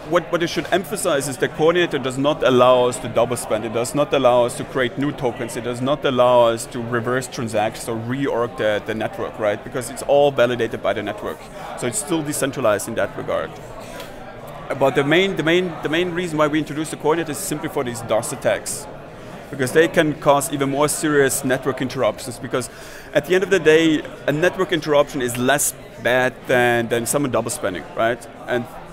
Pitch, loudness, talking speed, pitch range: 140 Hz, -20 LUFS, 205 wpm, 125-155 Hz